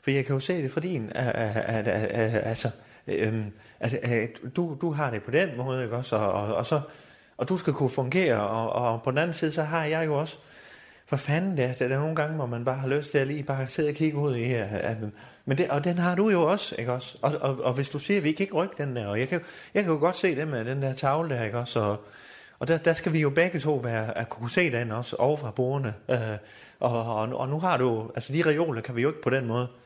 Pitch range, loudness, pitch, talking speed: 115-155 Hz, -27 LUFS, 135 Hz, 265 wpm